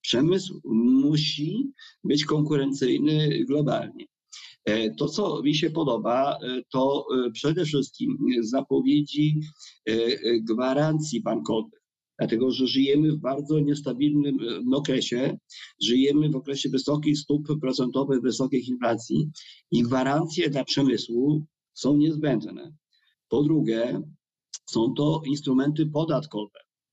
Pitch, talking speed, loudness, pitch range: 145 Hz, 95 wpm, -25 LUFS, 130-150 Hz